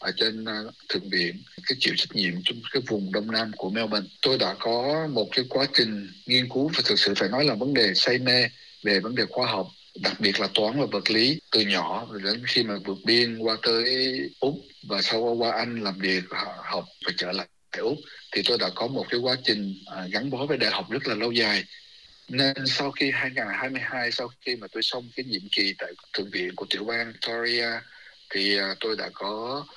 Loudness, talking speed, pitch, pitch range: -25 LUFS, 220 wpm, 115 Hz, 105-125 Hz